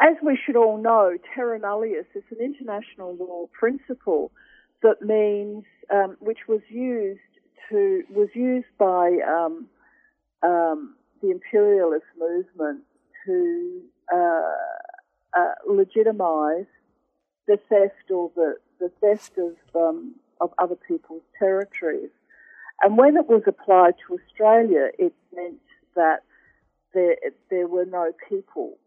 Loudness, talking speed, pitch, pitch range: -22 LUFS, 120 wpm, 215 Hz, 180-290 Hz